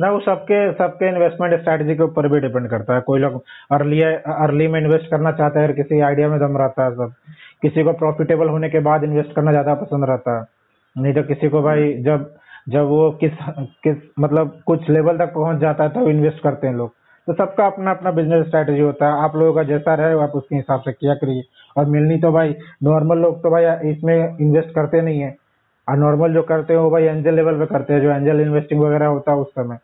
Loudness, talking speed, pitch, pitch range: -17 LUFS, 230 wpm, 150 Hz, 145-160 Hz